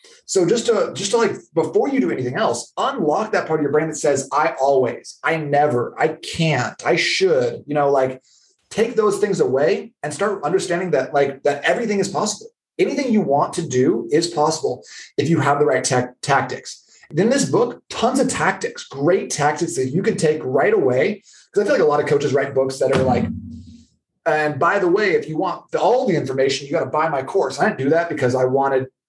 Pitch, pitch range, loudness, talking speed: 155 Hz, 140-205 Hz, -19 LUFS, 220 wpm